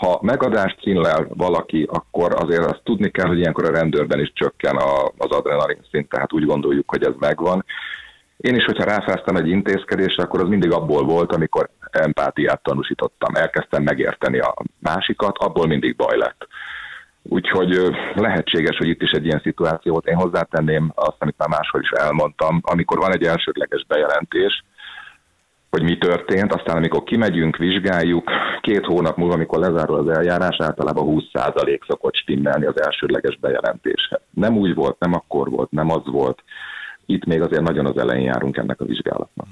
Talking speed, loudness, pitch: 165 wpm, -19 LUFS, 320 Hz